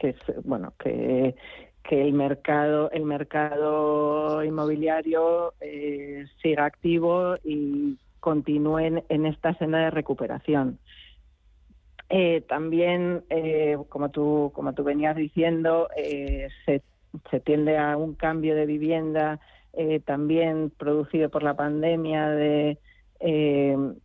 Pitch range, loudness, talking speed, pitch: 145-160 Hz, -25 LUFS, 115 wpm, 150 Hz